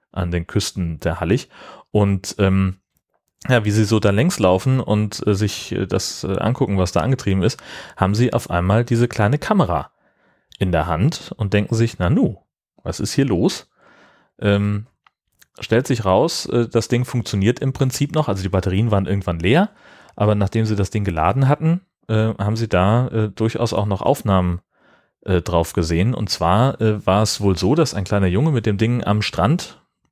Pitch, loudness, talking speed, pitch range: 105 Hz, -19 LUFS, 190 wpm, 95-120 Hz